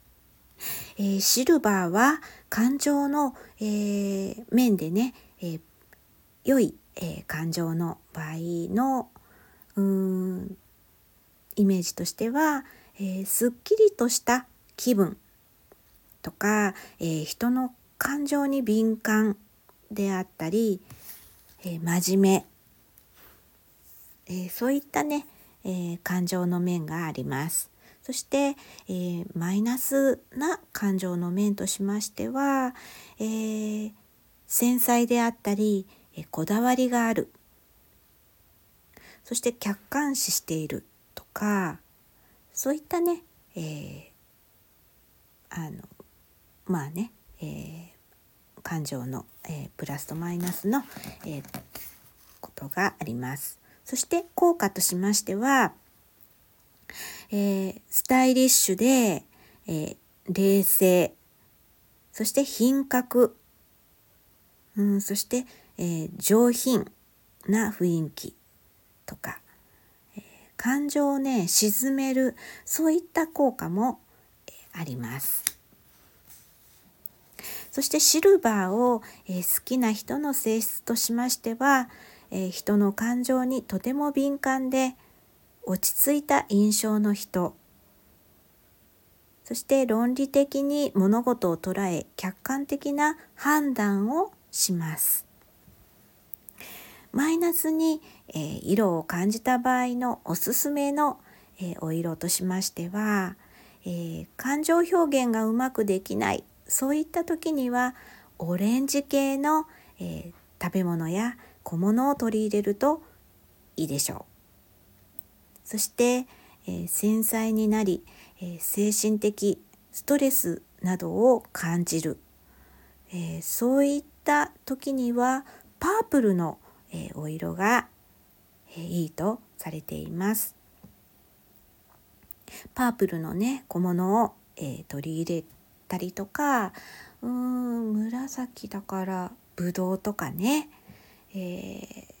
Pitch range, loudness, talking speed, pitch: 180-255 Hz, -26 LUFS, 195 characters per minute, 210 Hz